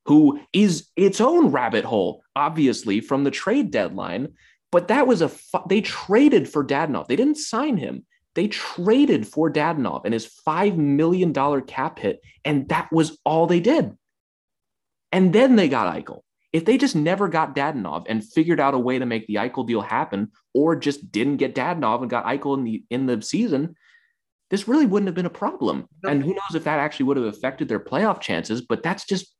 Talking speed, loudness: 200 wpm, -21 LUFS